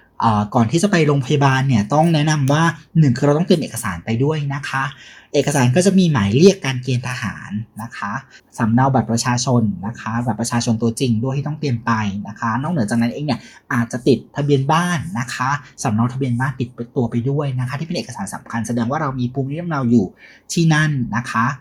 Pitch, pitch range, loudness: 130 Hz, 115-145 Hz, -18 LUFS